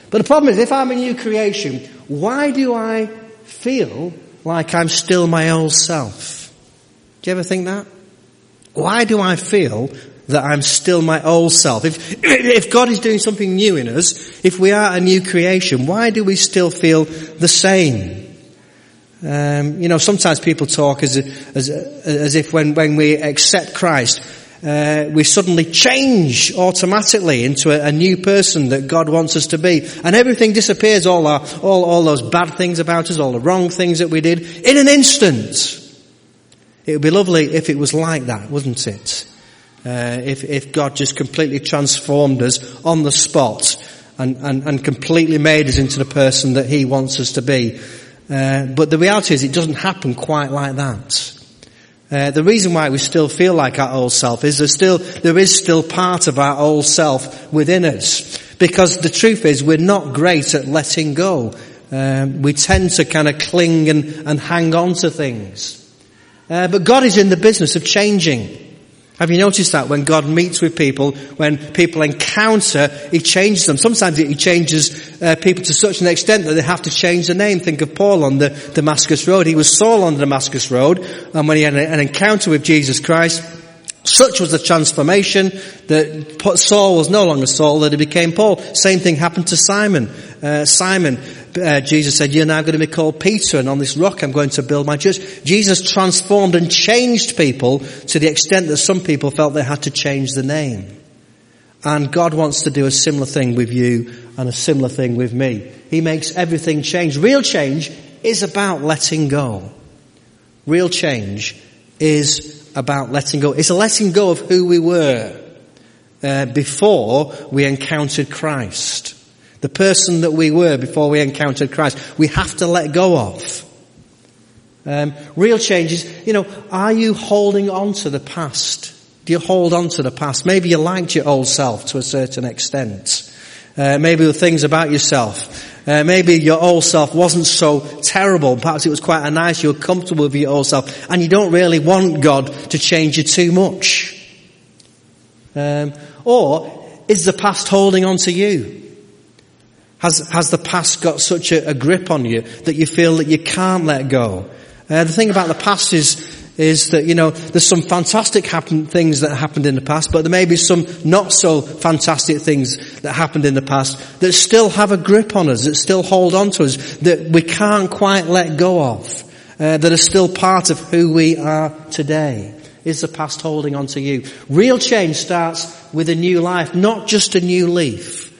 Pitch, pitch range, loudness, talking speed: 160 Hz, 145-180 Hz, -14 LUFS, 190 wpm